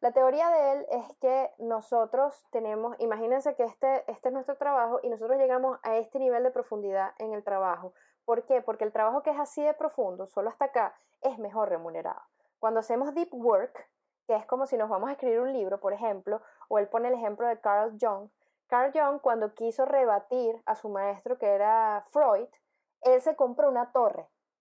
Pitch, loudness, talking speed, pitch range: 240 Hz, -29 LUFS, 200 wpm, 215-270 Hz